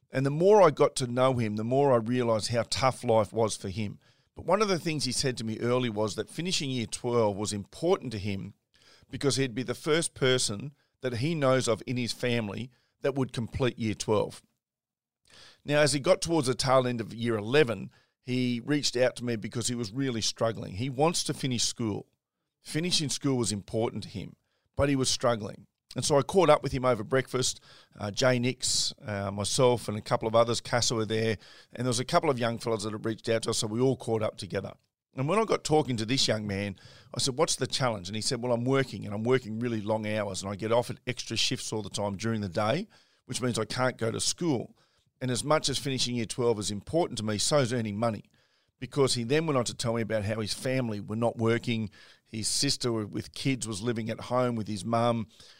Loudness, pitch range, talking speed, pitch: -28 LUFS, 110-130 Hz, 235 wpm, 120 Hz